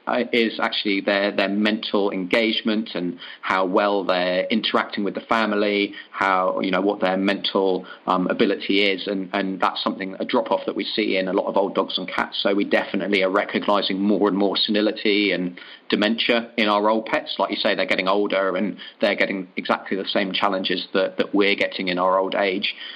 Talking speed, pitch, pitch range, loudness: 200 wpm, 100 Hz, 95-105 Hz, -21 LUFS